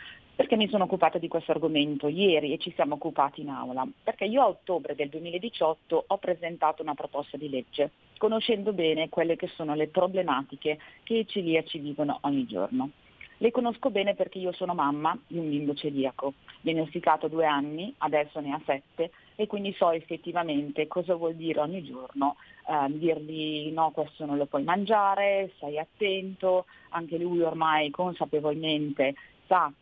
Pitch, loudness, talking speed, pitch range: 160 Hz, -29 LUFS, 165 wpm, 150-185 Hz